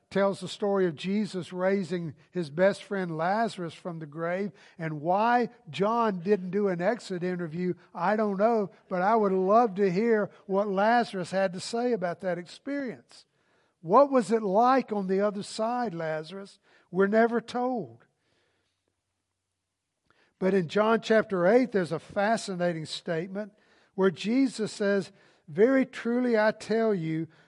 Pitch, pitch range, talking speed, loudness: 195 Hz, 175-220 Hz, 145 wpm, -27 LUFS